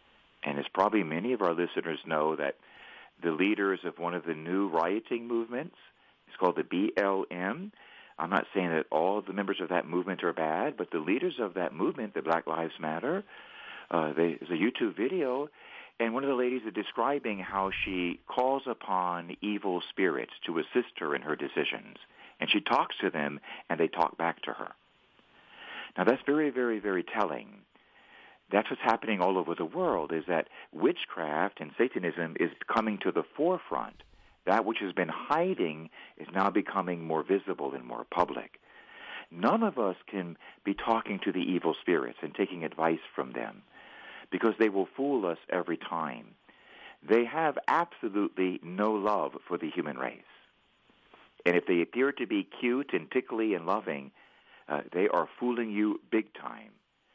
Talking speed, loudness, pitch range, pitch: 170 wpm, -31 LUFS, 85-120 Hz, 100 Hz